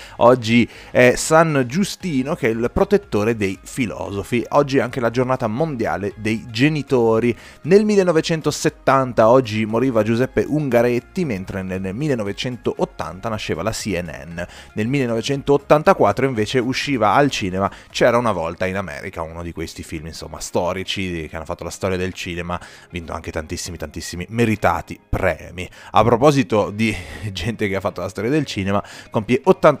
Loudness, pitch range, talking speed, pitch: -19 LUFS, 90-130 Hz, 145 wpm, 110 Hz